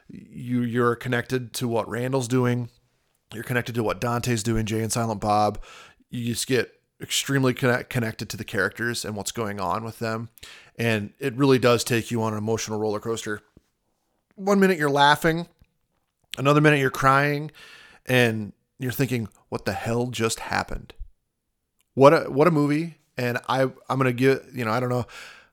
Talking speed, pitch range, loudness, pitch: 175 wpm, 115-130 Hz, -24 LUFS, 120 Hz